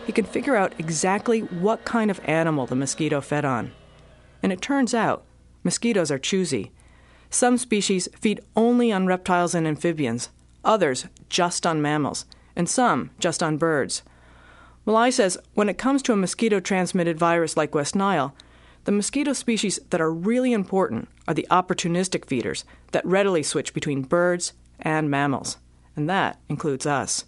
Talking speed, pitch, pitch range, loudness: 160 wpm, 175 Hz, 145-205 Hz, -23 LUFS